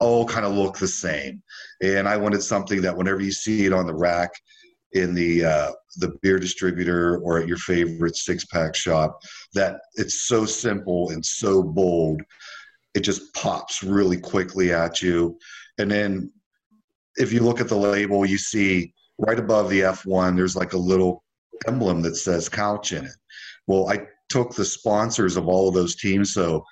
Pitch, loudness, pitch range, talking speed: 95 Hz, -22 LUFS, 90-105 Hz, 180 wpm